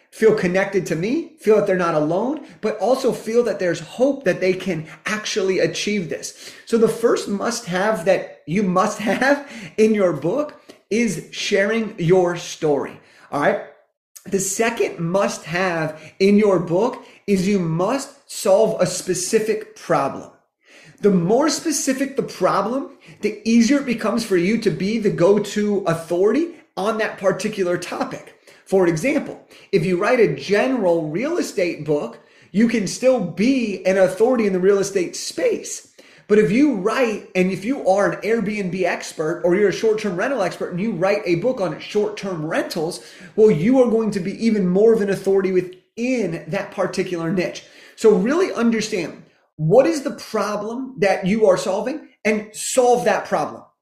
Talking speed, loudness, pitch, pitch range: 165 wpm, -20 LUFS, 205 Hz, 185-230 Hz